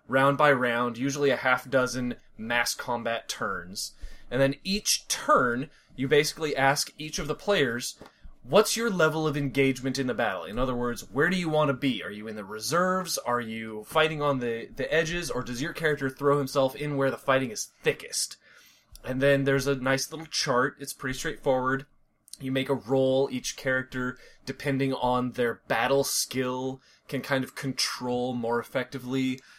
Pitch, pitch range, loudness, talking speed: 135 Hz, 125-145 Hz, -27 LUFS, 180 wpm